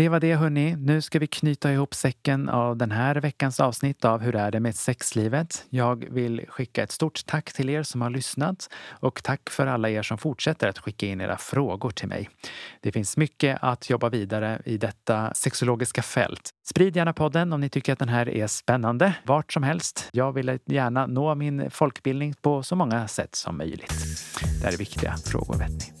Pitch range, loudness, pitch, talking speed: 110-145 Hz, -26 LUFS, 130 Hz, 205 wpm